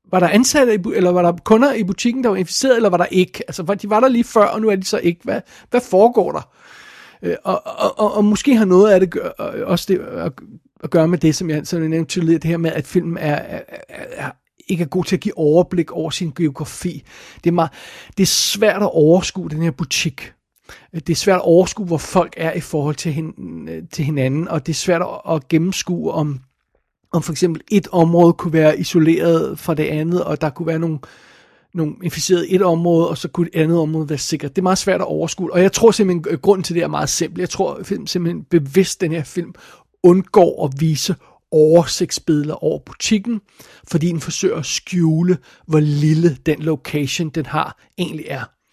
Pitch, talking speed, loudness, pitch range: 170 Hz, 215 wpm, -17 LUFS, 160-185 Hz